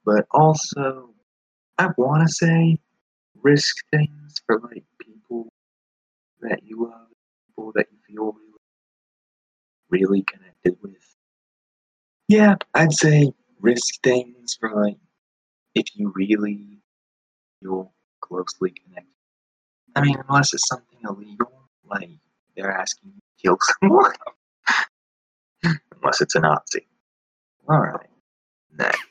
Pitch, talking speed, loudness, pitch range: 115 Hz, 115 wpm, -21 LUFS, 100-145 Hz